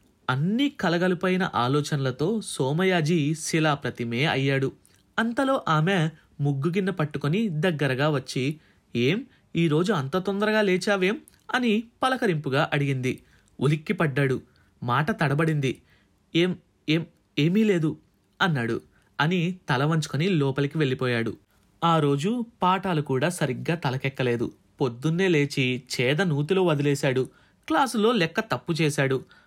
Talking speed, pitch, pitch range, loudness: 100 wpm, 155 Hz, 140-185 Hz, -25 LUFS